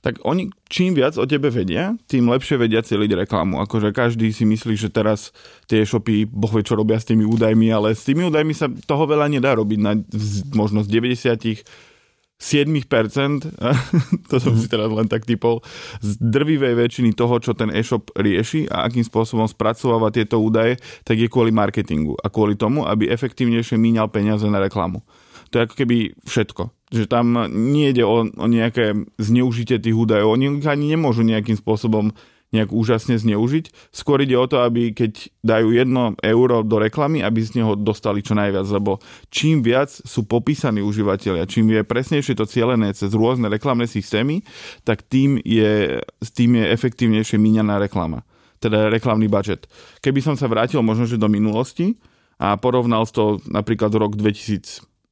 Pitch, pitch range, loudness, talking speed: 115 Hz, 110-125 Hz, -19 LUFS, 165 wpm